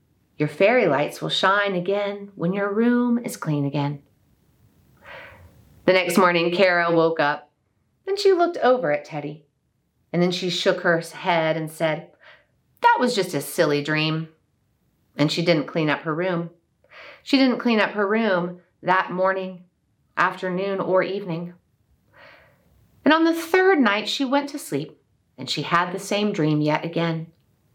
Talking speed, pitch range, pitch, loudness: 160 wpm, 155-200 Hz, 175 Hz, -22 LUFS